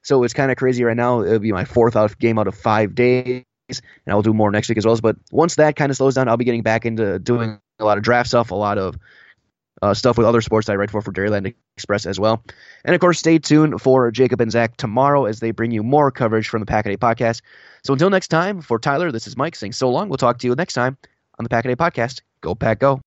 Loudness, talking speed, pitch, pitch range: -18 LUFS, 275 wpm, 120 Hz, 110-135 Hz